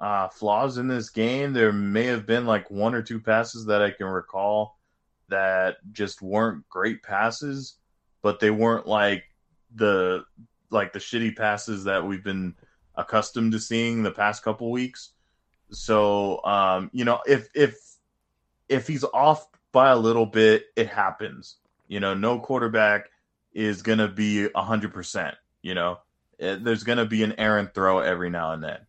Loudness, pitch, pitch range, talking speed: -24 LUFS, 105 Hz, 95-115 Hz, 165 wpm